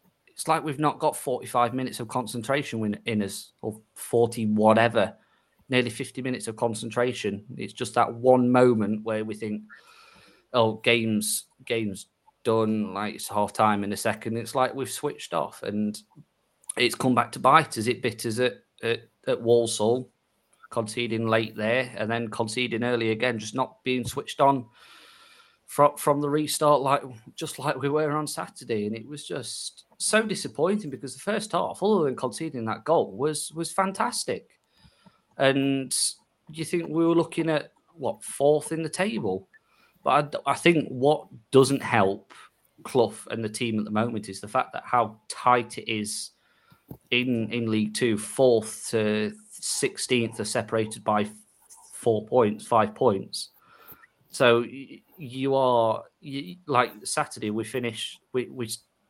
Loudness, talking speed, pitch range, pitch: -26 LUFS, 160 wpm, 110-145 Hz, 125 Hz